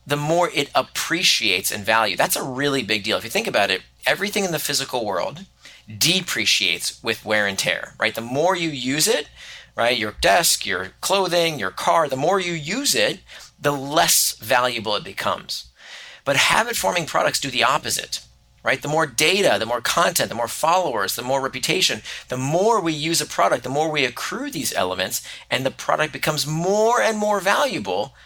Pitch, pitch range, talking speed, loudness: 155 Hz, 135-185 Hz, 185 wpm, -20 LUFS